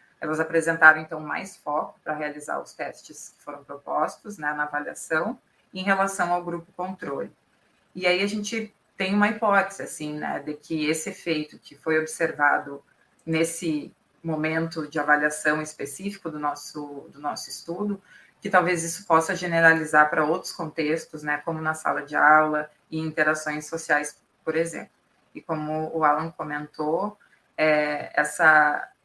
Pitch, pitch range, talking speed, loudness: 160 Hz, 150-175 Hz, 150 wpm, -24 LUFS